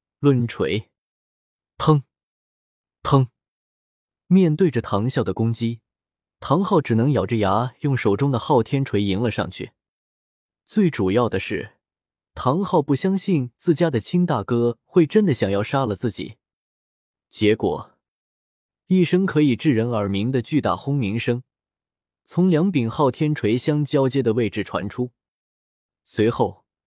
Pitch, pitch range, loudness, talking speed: 125 Hz, 105-150 Hz, -21 LUFS, 195 characters per minute